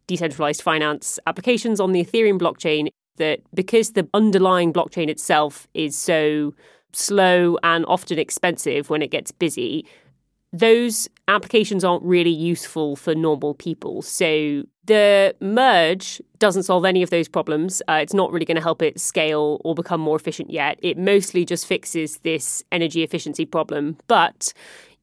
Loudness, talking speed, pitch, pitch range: -20 LUFS, 150 wpm, 170 Hz, 155-190 Hz